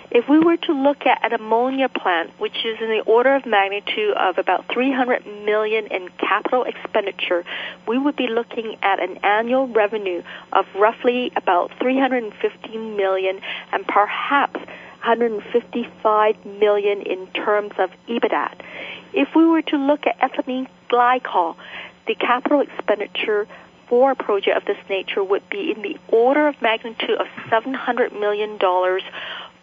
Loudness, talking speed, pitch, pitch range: -20 LUFS, 145 wpm, 235 Hz, 210-275 Hz